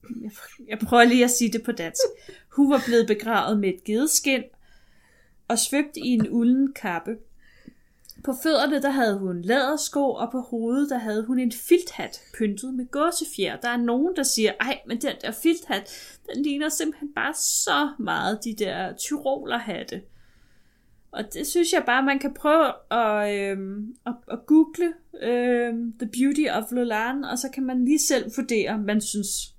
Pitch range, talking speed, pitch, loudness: 225-285 Hz, 175 wpm, 245 Hz, -24 LUFS